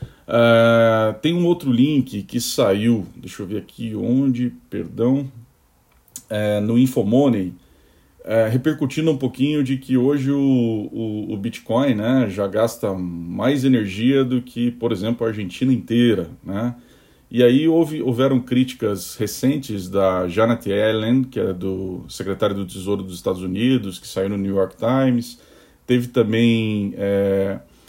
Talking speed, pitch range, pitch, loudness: 145 wpm, 100-130 Hz, 115 Hz, -20 LUFS